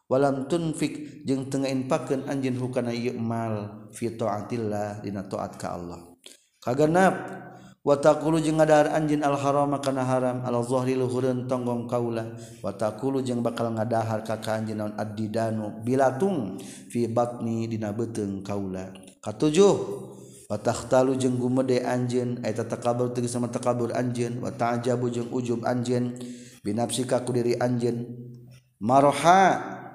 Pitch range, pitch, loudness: 115-130 Hz, 120 Hz, -26 LUFS